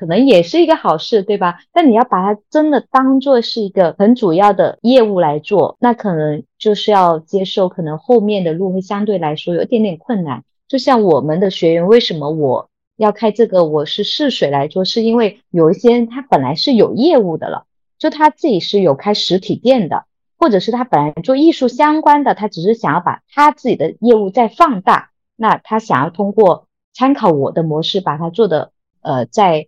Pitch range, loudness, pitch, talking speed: 175-245 Hz, -14 LUFS, 210 Hz, 295 characters per minute